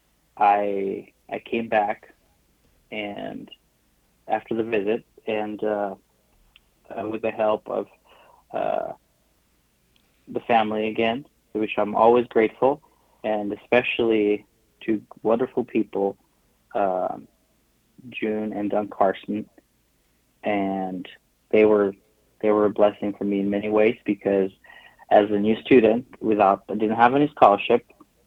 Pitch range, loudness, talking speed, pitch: 100-110 Hz, -23 LUFS, 120 wpm, 105 Hz